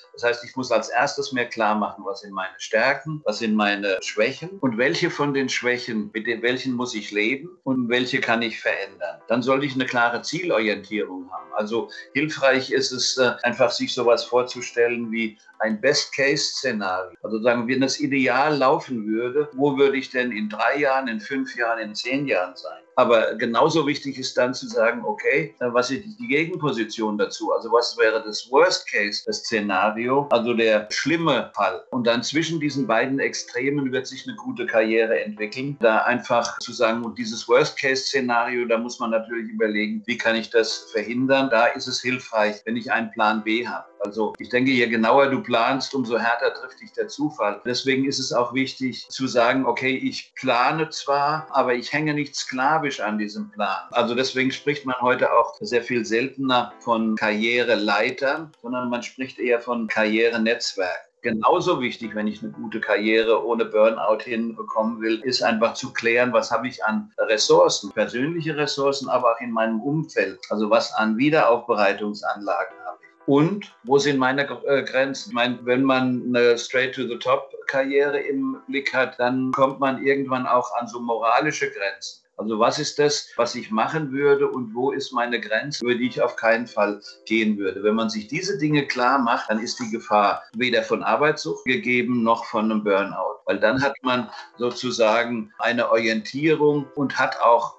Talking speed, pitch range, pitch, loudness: 180 wpm, 115-140 Hz, 125 Hz, -22 LUFS